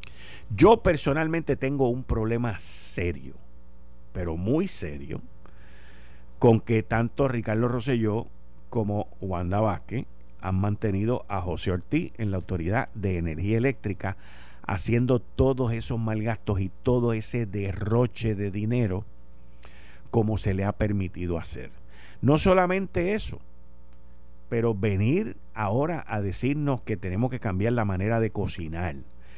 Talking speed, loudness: 125 wpm, -27 LUFS